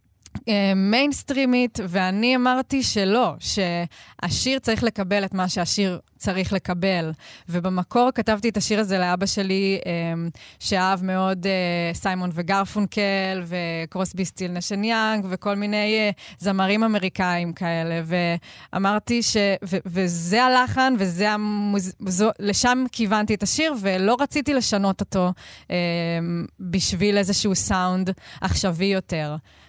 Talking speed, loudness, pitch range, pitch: 110 wpm, -22 LUFS, 180-215 Hz, 195 Hz